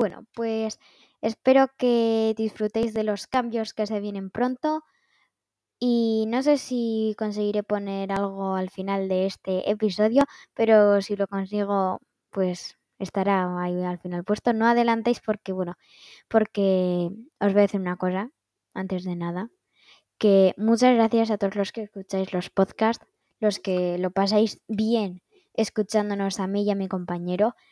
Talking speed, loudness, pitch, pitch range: 150 wpm, -25 LUFS, 210 Hz, 190-225 Hz